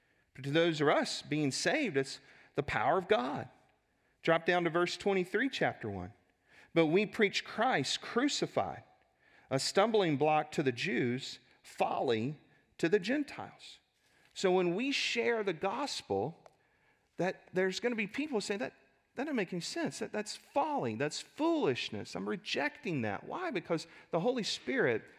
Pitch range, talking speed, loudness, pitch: 150-230 Hz, 155 wpm, -33 LUFS, 185 Hz